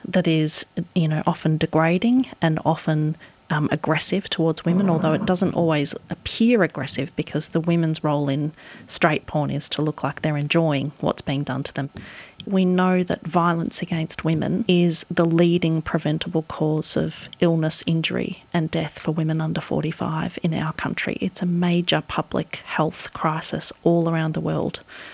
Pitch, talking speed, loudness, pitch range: 160 Hz, 165 wpm, -22 LUFS, 155-175 Hz